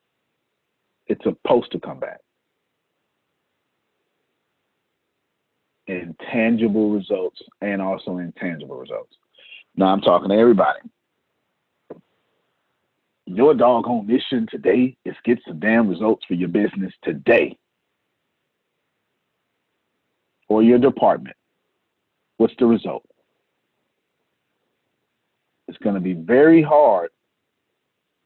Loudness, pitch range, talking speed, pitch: -19 LUFS, 95-125 Hz, 90 wpm, 115 Hz